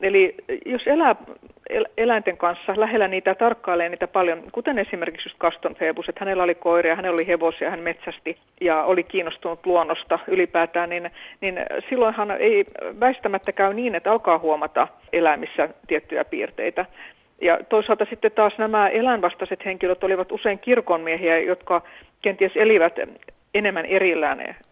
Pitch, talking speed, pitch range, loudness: 190 Hz, 140 wpm, 170-220 Hz, -22 LUFS